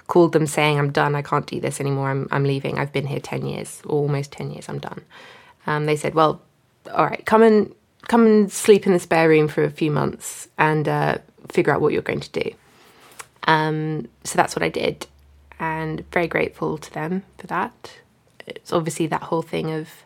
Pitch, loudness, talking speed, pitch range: 155 Hz, -21 LUFS, 210 wpm, 145-175 Hz